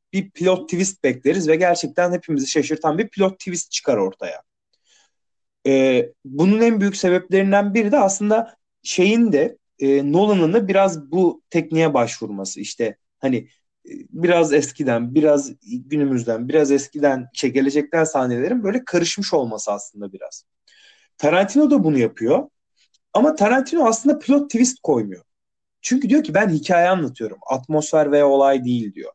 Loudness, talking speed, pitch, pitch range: -19 LUFS, 140 wpm, 170 Hz, 140-200 Hz